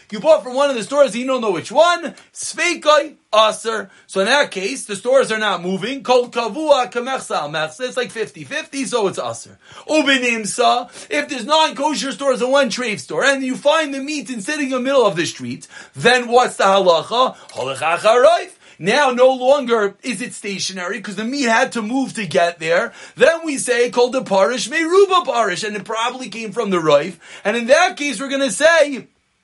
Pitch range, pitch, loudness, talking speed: 210-280 Hz, 250 Hz, -17 LUFS, 200 wpm